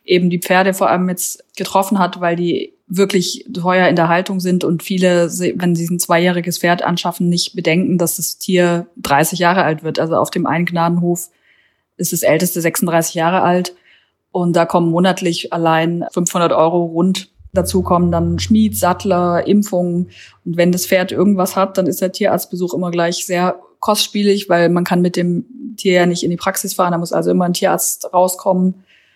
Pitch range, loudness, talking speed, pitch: 170-185 Hz, -16 LUFS, 185 wpm, 180 Hz